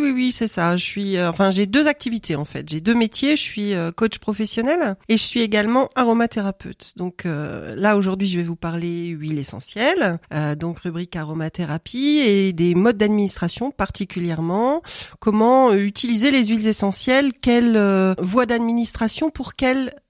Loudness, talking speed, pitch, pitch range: -19 LUFS, 160 wpm, 210 Hz, 175-240 Hz